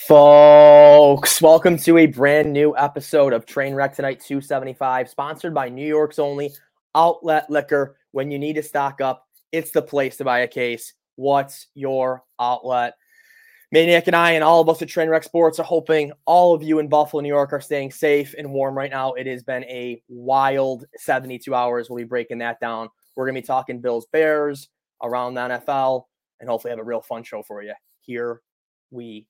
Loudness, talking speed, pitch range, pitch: -17 LUFS, 190 wpm, 125-155 Hz, 140 Hz